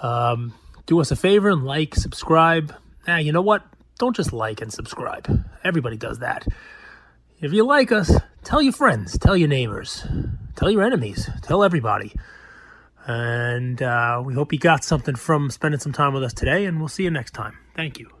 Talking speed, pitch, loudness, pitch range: 190 wpm, 150 Hz, -21 LUFS, 120-170 Hz